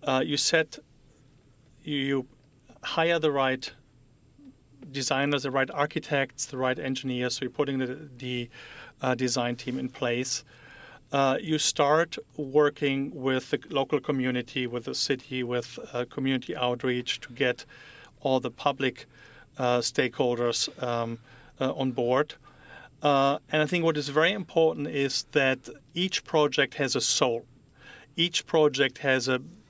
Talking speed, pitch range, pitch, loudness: 140 wpm, 125-145 Hz, 135 Hz, -27 LUFS